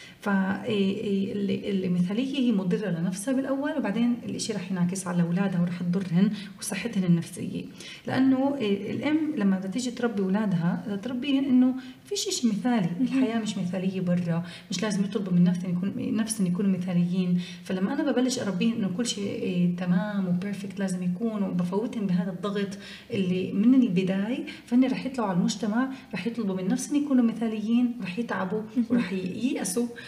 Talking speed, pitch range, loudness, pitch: 145 wpm, 190-240 Hz, -27 LUFS, 205 Hz